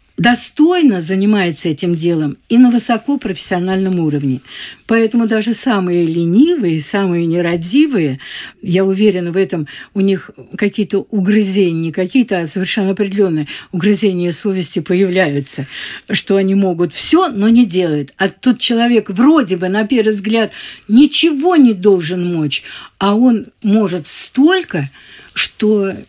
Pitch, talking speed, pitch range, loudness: 195 Hz, 120 wpm, 175-230 Hz, -14 LUFS